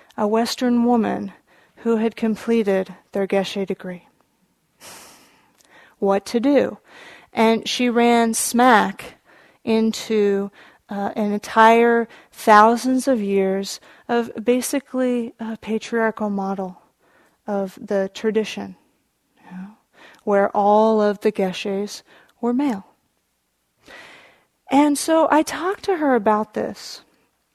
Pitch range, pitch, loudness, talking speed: 200-240 Hz, 225 Hz, -20 LUFS, 105 wpm